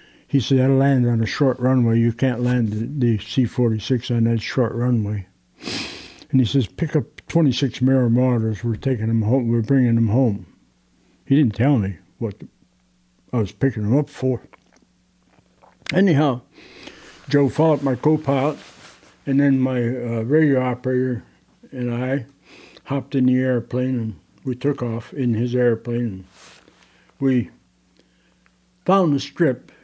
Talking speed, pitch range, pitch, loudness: 150 wpm, 115-135 Hz, 125 Hz, -20 LUFS